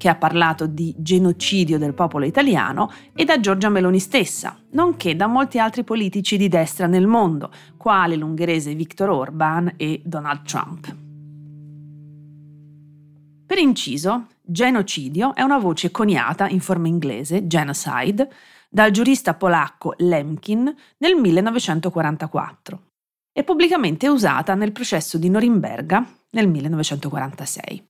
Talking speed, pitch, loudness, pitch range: 120 wpm, 175 Hz, -19 LUFS, 155-215 Hz